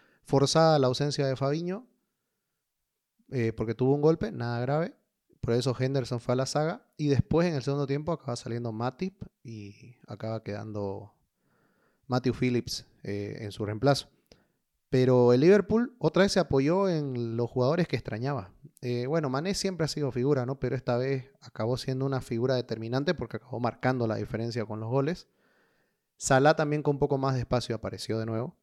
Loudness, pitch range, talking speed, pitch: -28 LUFS, 120-145 Hz, 175 wpm, 130 Hz